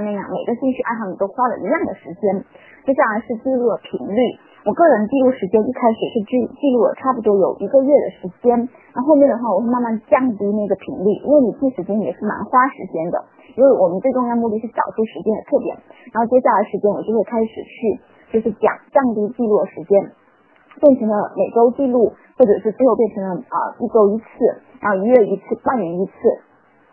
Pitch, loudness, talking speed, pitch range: 230 Hz, -18 LUFS, 335 characters per minute, 205-260 Hz